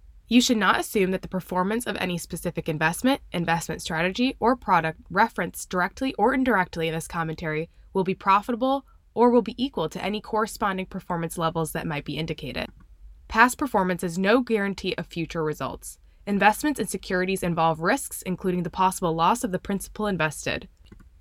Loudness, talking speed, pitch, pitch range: -25 LUFS, 165 wpm, 185 Hz, 165-220 Hz